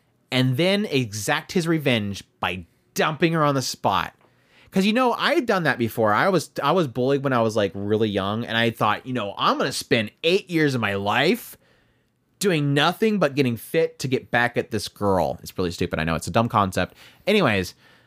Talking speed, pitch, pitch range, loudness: 215 wpm, 120 Hz, 100-155 Hz, -22 LUFS